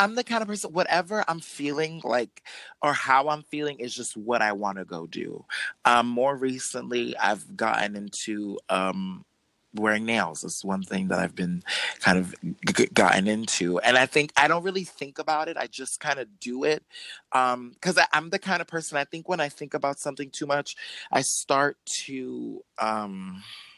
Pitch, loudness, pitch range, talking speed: 130 Hz, -26 LUFS, 100-155 Hz, 190 wpm